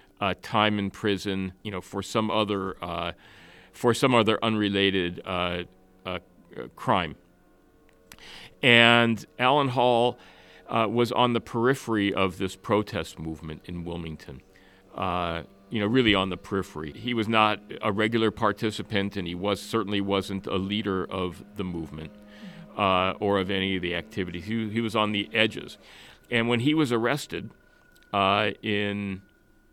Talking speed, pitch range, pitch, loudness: 150 wpm, 95-110 Hz, 100 Hz, -26 LUFS